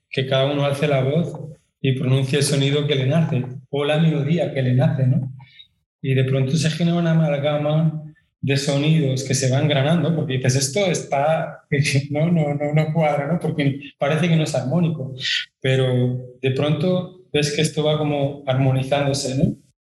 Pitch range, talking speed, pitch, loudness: 135-155 Hz, 180 wpm, 145 Hz, -20 LUFS